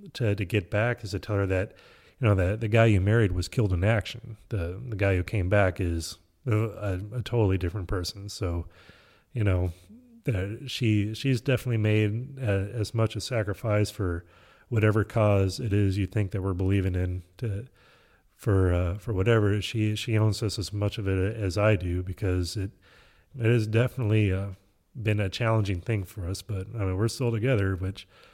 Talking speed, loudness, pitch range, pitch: 195 wpm, -27 LUFS, 95-110 Hz, 105 Hz